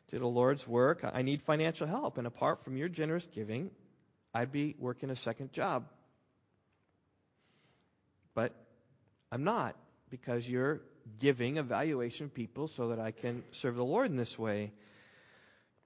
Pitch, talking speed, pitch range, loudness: 125 Hz, 150 wpm, 115-140 Hz, -36 LUFS